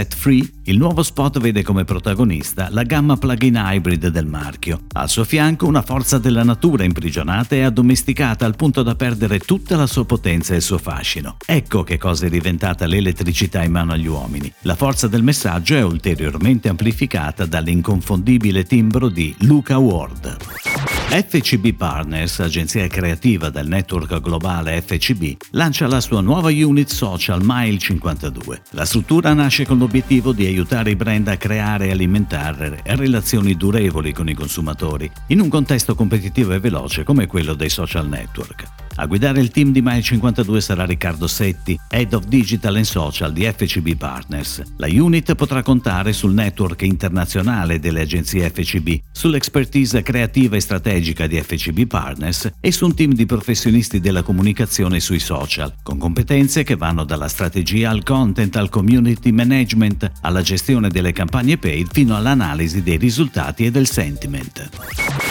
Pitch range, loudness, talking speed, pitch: 85-125 Hz, -17 LUFS, 155 wpm, 100 Hz